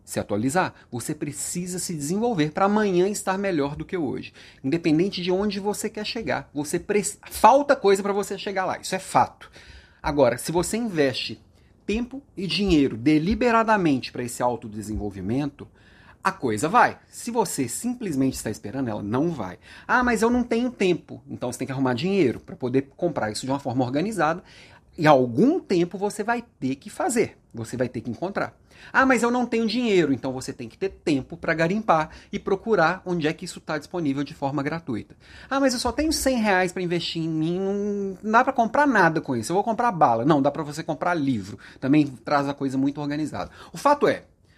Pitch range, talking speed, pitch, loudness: 135-205 Hz, 200 wpm, 170 Hz, -24 LUFS